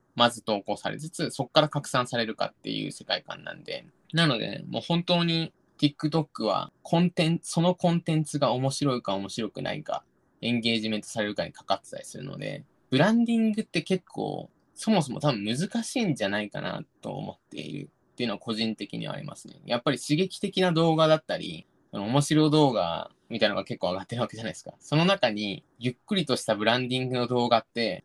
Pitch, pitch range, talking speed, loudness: 150 Hz, 120-170 Hz, 440 characters per minute, -27 LUFS